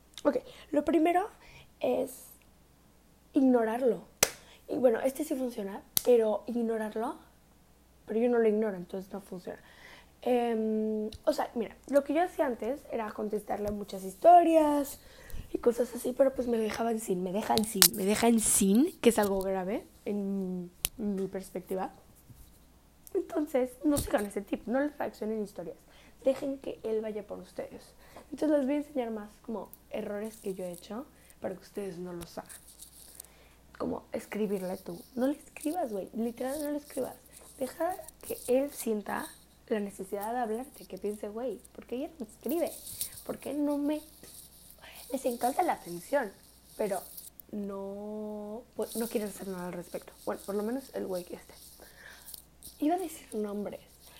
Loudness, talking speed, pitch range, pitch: -31 LUFS, 155 wpm, 205-275 Hz, 230 Hz